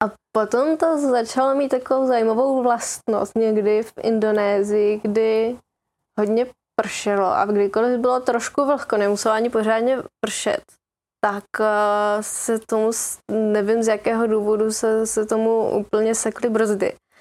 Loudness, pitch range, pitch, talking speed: -20 LUFS, 215-240 Hz, 225 Hz, 125 wpm